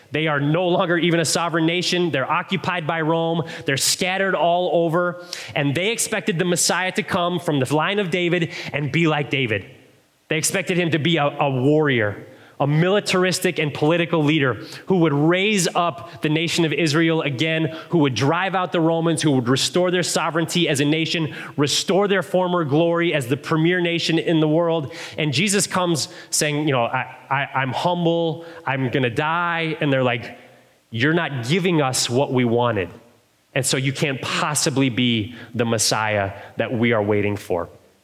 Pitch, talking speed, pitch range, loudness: 160 Hz, 185 wpm, 140-175 Hz, -20 LUFS